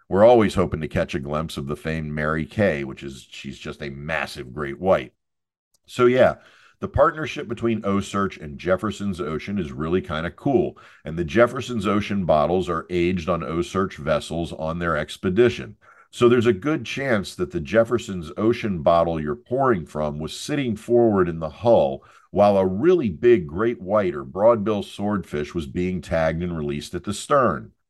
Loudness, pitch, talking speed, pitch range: -22 LUFS, 90 Hz, 180 wpm, 80-110 Hz